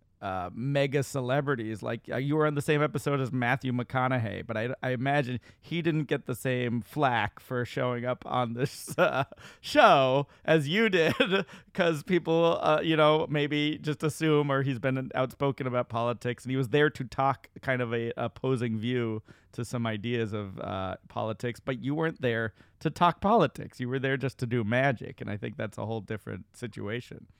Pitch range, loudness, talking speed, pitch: 120-145 Hz, -29 LUFS, 190 wpm, 130 Hz